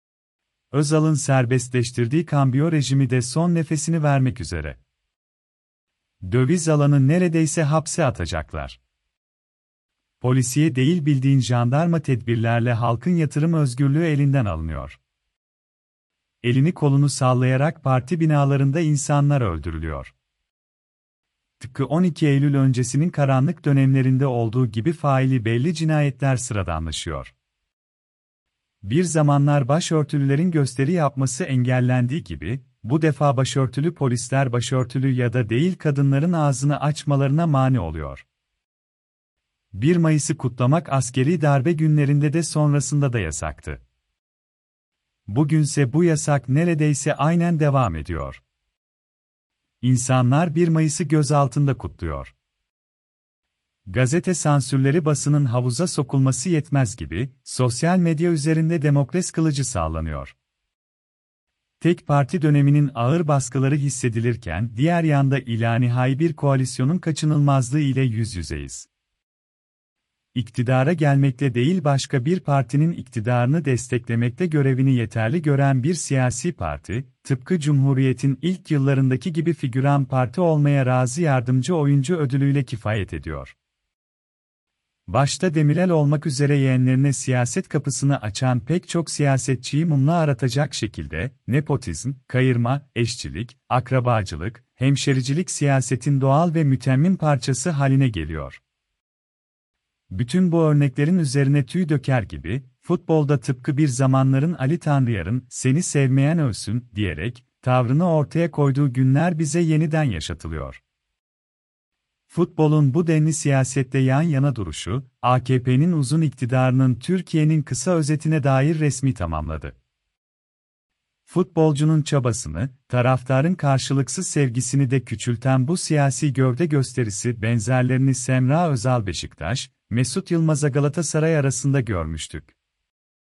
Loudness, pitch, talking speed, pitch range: -21 LUFS, 135 Hz, 100 wpm, 120-155 Hz